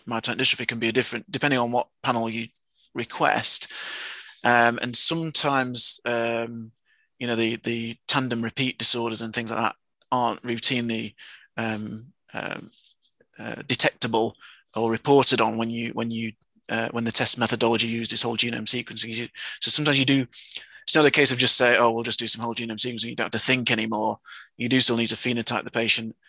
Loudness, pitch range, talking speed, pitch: -22 LUFS, 115-125 Hz, 185 wpm, 115 Hz